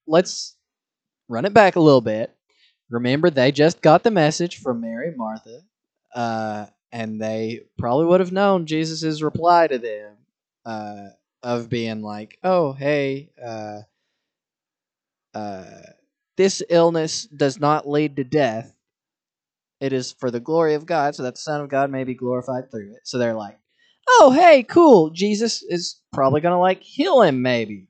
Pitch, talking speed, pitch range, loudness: 140 Hz, 160 wpm, 115-175 Hz, -19 LUFS